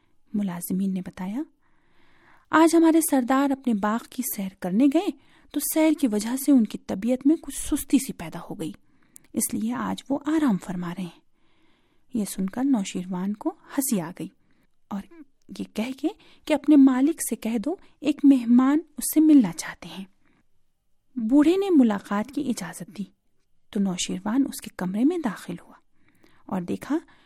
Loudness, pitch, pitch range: -24 LUFS, 255 Hz, 200-295 Hz